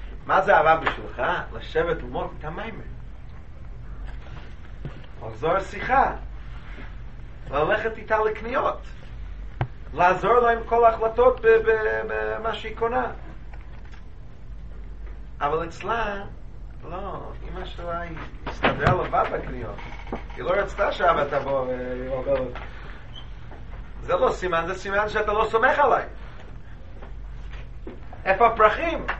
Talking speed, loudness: 95 wpm, -23 LUFS